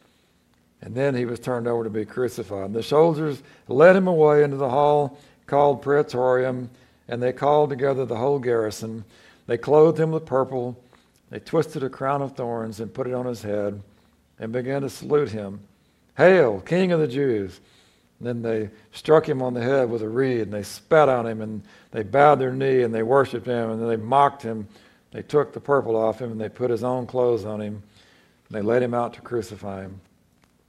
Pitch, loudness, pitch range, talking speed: 120 Hz, -22 LUFS, 110-140 Hz, 205 wpm